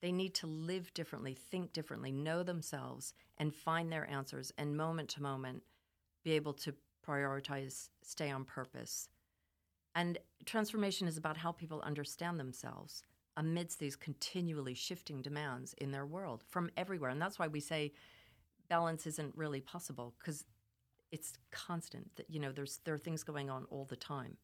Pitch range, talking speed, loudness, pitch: 135-165 Hz, 160 wpm, -42 LUFS, 150 Hz